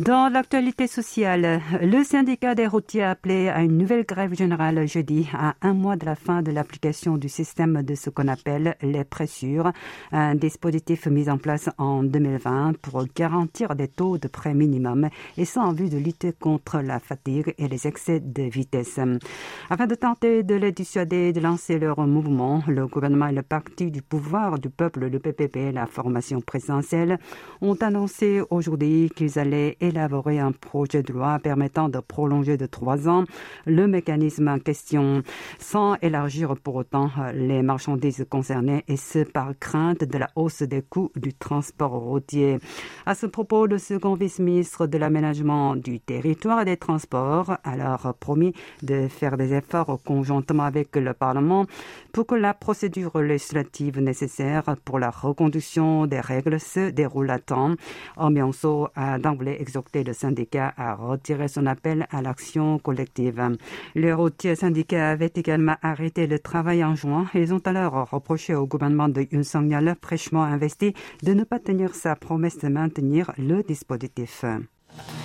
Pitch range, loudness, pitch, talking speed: 140-170 Hz, -24 LUFS, 155 Hz, 165 wpm